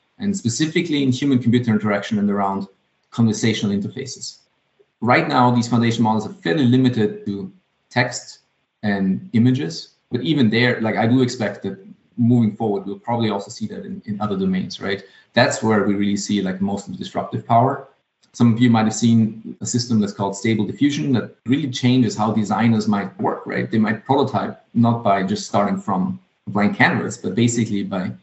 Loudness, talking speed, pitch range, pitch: -20 LUFS, 180 wpm, 100-125 Hz, 110 Hz